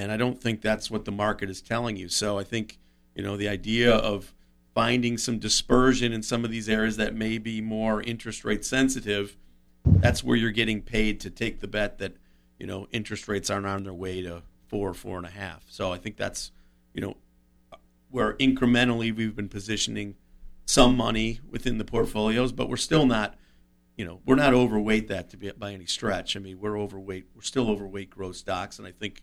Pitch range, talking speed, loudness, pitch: 95-115 Hz, 210 wpm, -26 LUFS, 105 Hz